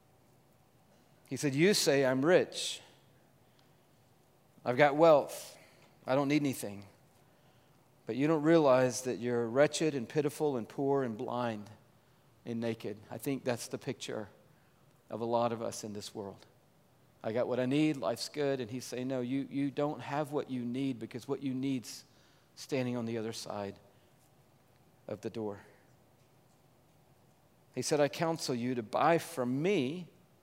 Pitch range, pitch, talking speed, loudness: 120-145 Hz, 130 Hz, 160 wpm, -33 LUFS